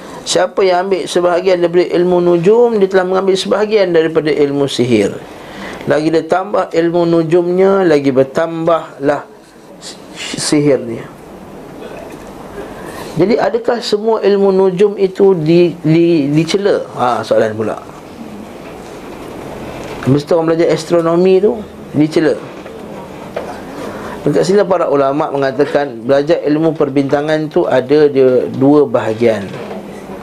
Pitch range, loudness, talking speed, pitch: 145-190 Hz, -13 LUFS, 105 wpm, 165 Hz